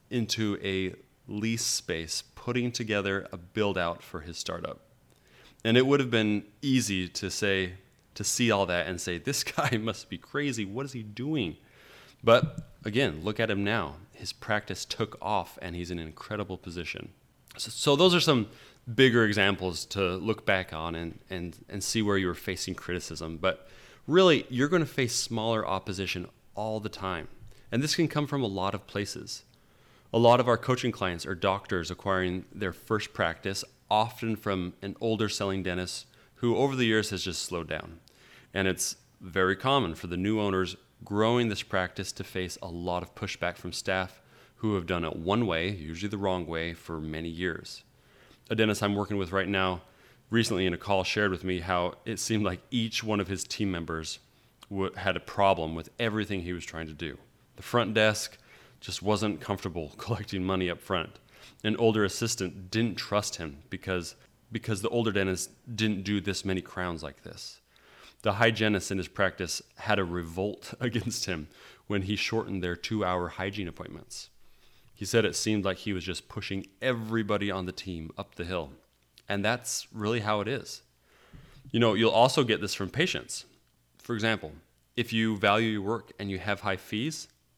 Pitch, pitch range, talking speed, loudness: 100 Hz, 90-115 Hz, 185 wpm, -29 LUFS